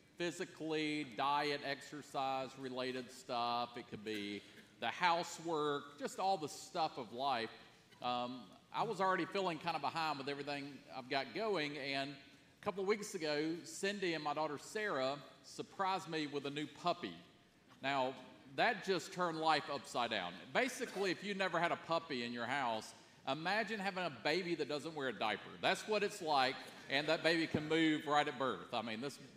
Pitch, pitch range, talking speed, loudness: 150 Hz, 135-170 Hz, 180 wpm, -39 LUFS